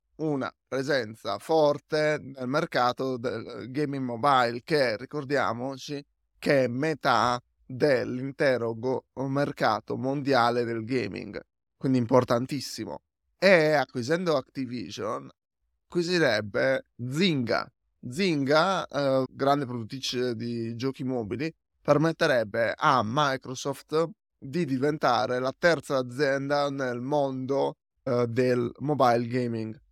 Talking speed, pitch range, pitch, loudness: 95 wpm, 125-145 Hz, 135 Hz, -27 LUFS